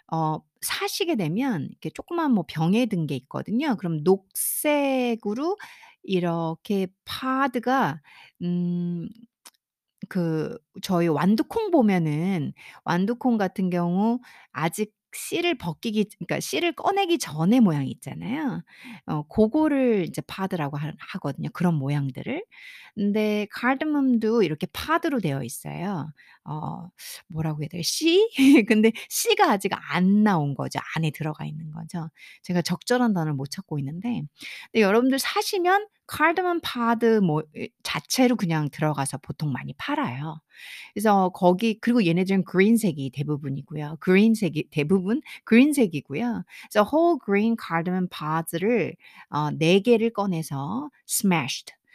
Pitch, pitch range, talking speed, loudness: 195 Hz, 160-245 Hz, 290 characters per minute, -24 LUFS